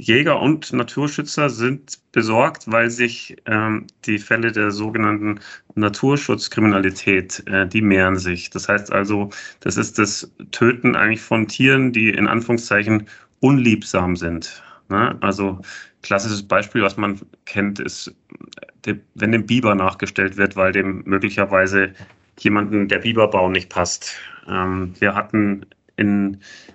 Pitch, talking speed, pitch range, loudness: 105 Hz, 125 wpm, 100-115 Hz, -19 LUFS